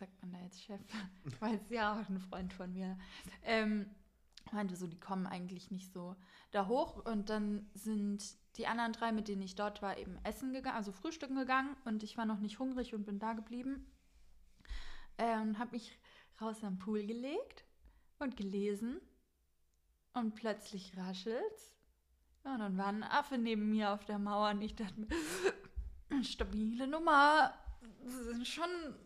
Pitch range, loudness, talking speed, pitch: 200-240 Hz, -39 LUFS, 165 wpm, 215 Hz